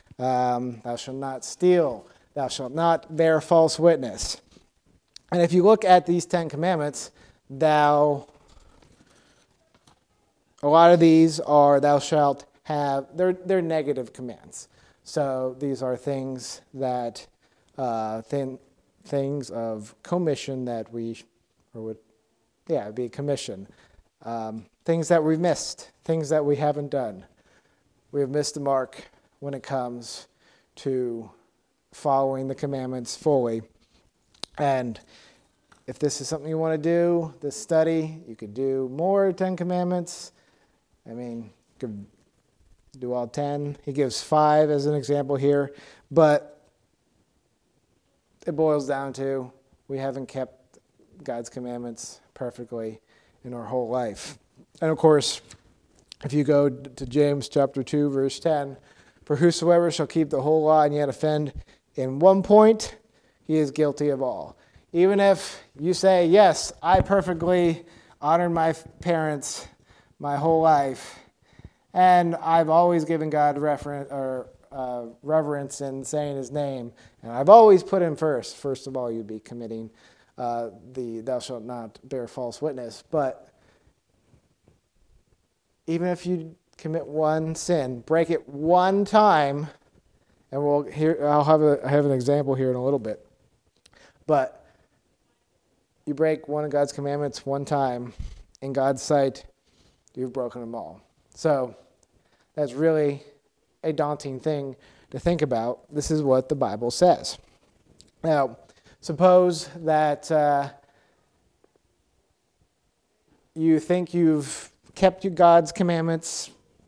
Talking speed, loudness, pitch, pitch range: 135 wpm, -23 LUFS, 145 Hz, 130-160 Hz